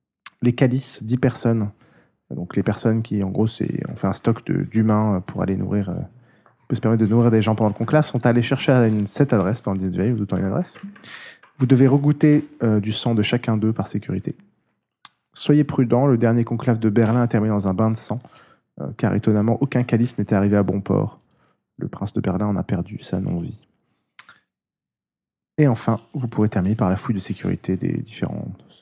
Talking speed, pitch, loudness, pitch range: 200 wpm, 115 Hz, -21 LUFS, 105-125 Hz